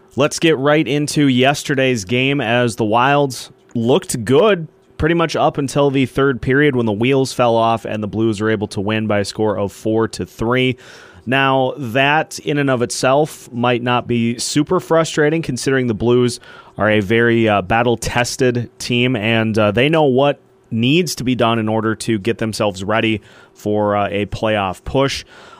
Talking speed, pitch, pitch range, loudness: 180 wpm, 120 Hz, 110-140 Hz, -16 LUFS